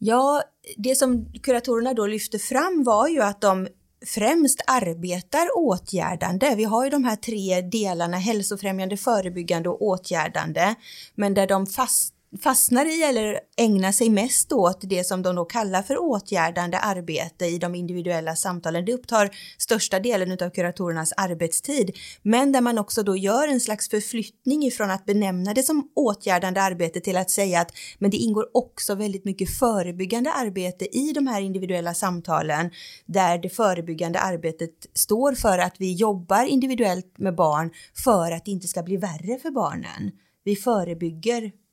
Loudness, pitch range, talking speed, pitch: -23 LUFS, 180-235 Hz, 160 wpm, 200 Hz